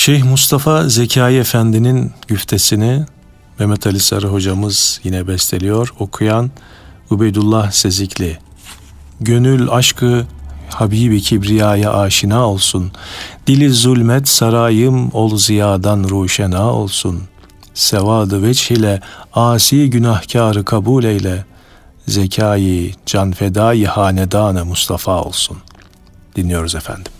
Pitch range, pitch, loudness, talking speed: 95-115 Hz, 105 Hz, -13 LUFS, 90 wpm